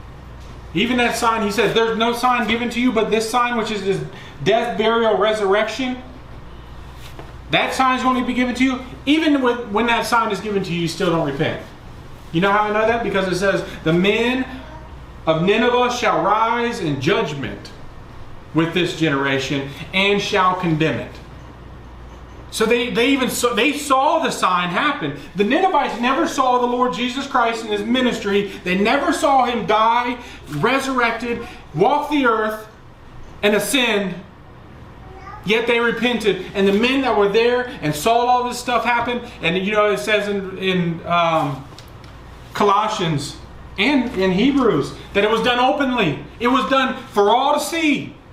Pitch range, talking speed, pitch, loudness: 190-245 Hz, 170 wpm, 225 Hz, -18 LUFS